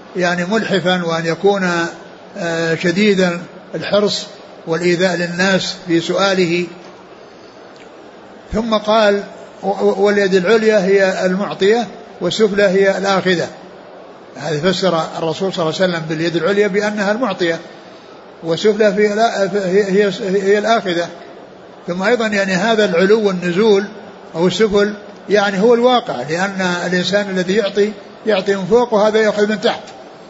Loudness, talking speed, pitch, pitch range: -15 LUFS, 115 wpm, 195 Hz, 175-210 Hz